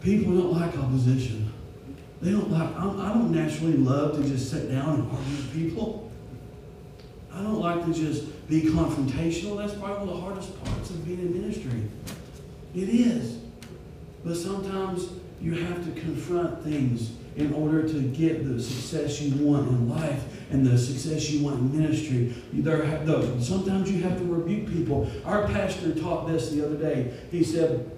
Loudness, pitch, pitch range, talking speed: -27 LUFS, 155 Hz, 140-175 Hz, 165 wpm